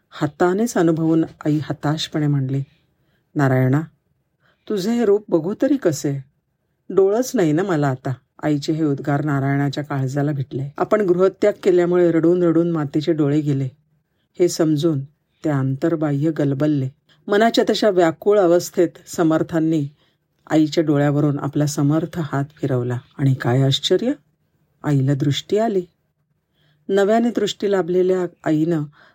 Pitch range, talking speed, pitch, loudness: 145-175 Hz, 115 wpm, 155 Hz, -19 LUFS